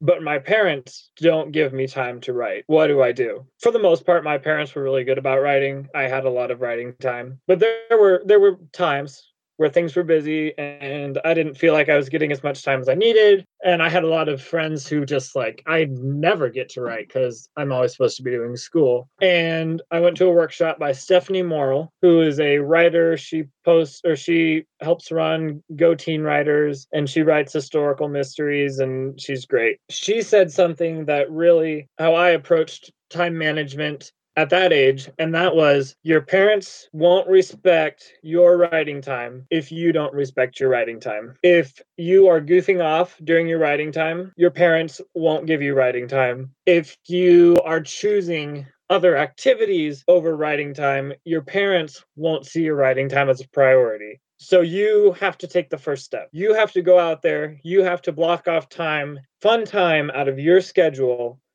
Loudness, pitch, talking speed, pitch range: -19 LUFS, 160 Hz, 195 wpm, 140-175 Hz